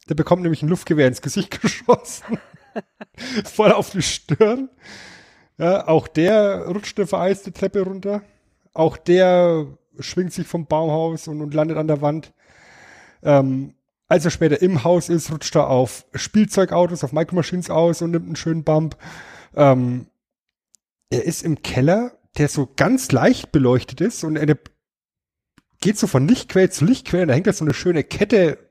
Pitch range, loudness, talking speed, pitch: 150-185 Hz, -19 LUFS, 160 wpm, 165 Hz